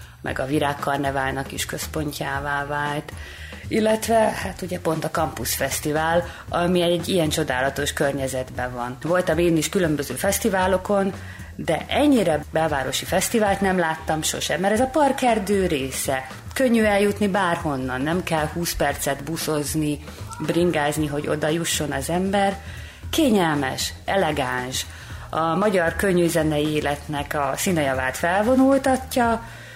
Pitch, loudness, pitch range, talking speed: 155 Hz, -22 LUFS, 140-190 Hz, 120 wpm